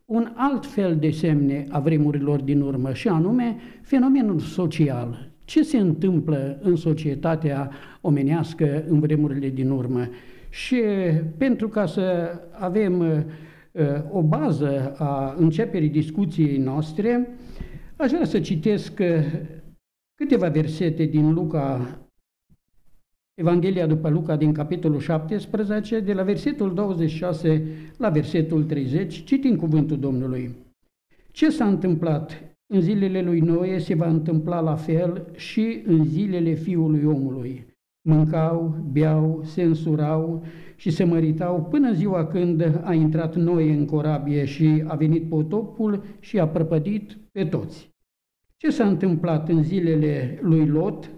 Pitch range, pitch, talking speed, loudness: 155-190 Hz, 165 Hz, 125 wpm, -22 LUFS